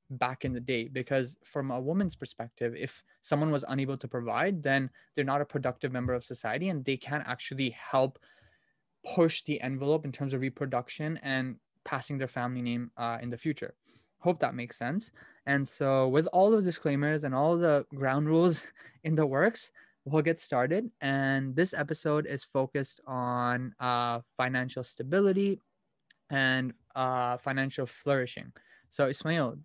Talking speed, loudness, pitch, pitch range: 160 wpm, -31 LUFS, 135 Hz, 125-155 Hz